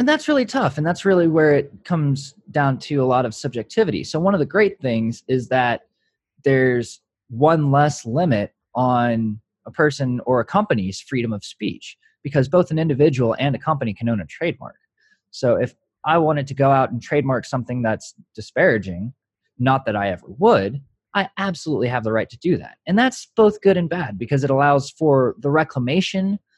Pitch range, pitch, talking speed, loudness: 120-165 Hz, 140 Hz, 190 wpm, -20 LUFS